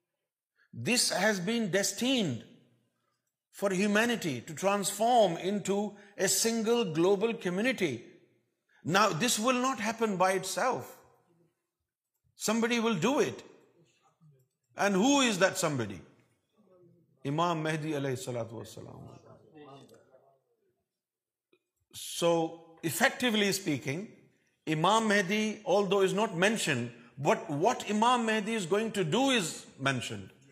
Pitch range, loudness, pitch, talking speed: 160-225 Hz, -29 LUFS, 195 Hz, 100 wpm